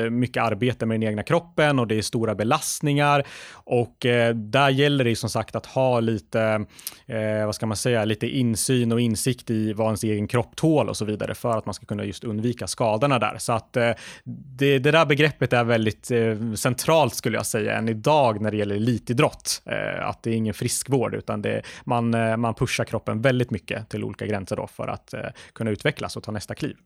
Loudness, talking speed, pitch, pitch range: -23 LUFS, 200 wpm, 115 Hz, 110-130 Hz